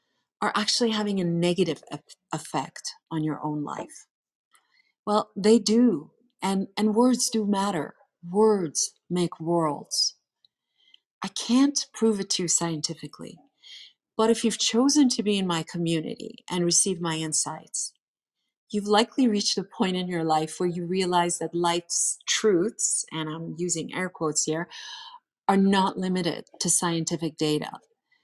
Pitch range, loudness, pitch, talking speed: 165-220 Hz, -25 LUFS, 185 Hz, 145 wpm